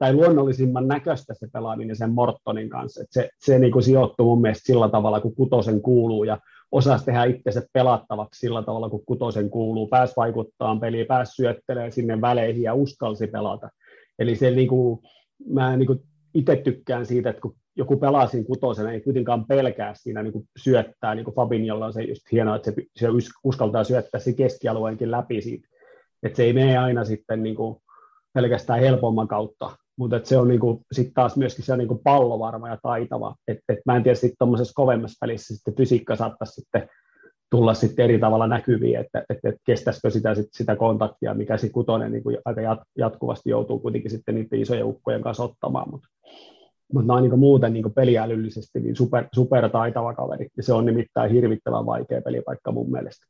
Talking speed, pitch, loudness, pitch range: 185 wpm, 120 Hz, -22 LUFS, 110-125 Hz